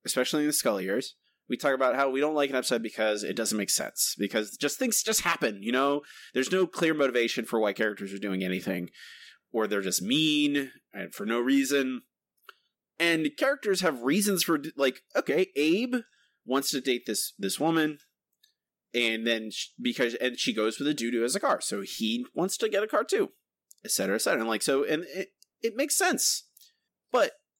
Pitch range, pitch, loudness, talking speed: 120-195 Hz, 140 Hz, -28 LUFS, 200 wpm